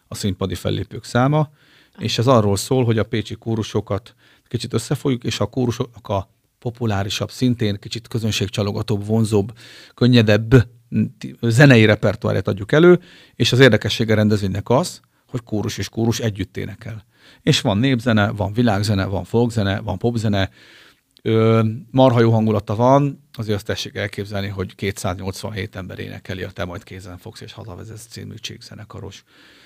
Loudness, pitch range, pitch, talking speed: -19 LUFS, 100-120 Hz, 110 Hz, 140 wpm